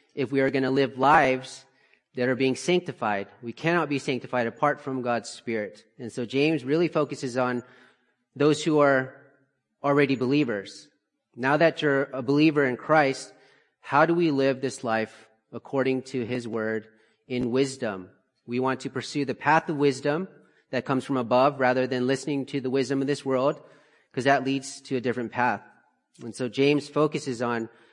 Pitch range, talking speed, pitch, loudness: 125-140 Hz, 175 wpm, 135 Hz, -25 LUFS